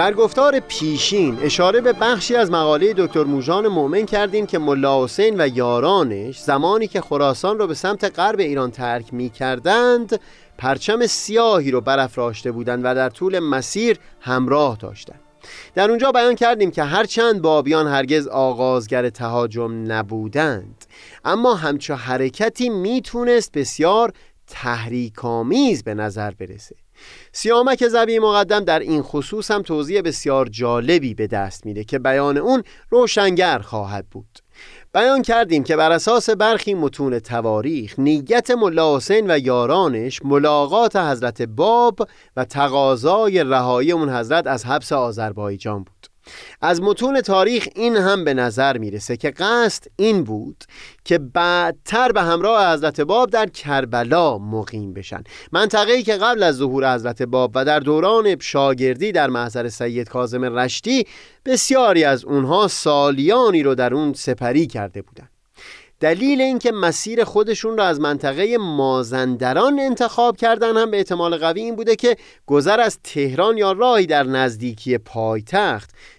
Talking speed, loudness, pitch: 140 wpm, -18 LUFS, 150 Hz